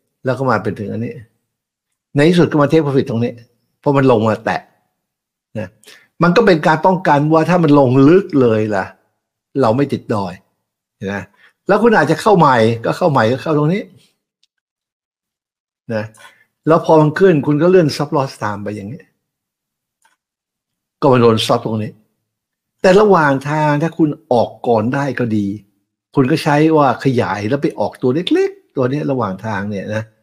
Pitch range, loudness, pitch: 110-155 Hz, -14 LUFS, 135 Hz